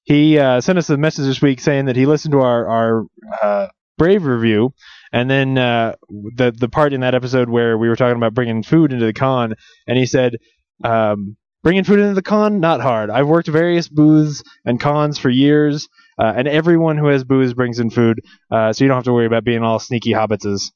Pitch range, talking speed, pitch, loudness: 115-150 Hz, 225 wpm, 125 Hz, -16 LUFS